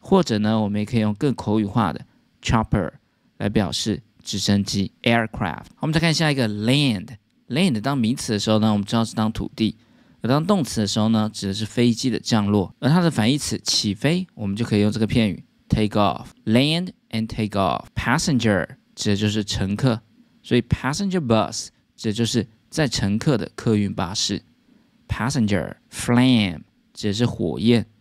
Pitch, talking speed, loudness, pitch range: 110 Hz, 390 characters per minute, -22 LUFS, 105-125 Hz